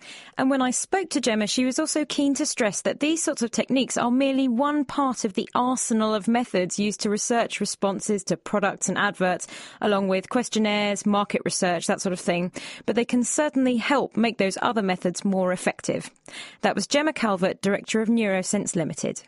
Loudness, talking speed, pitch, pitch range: -24 LUFS, 195 wpm, 220 Hz, 195-260 Hz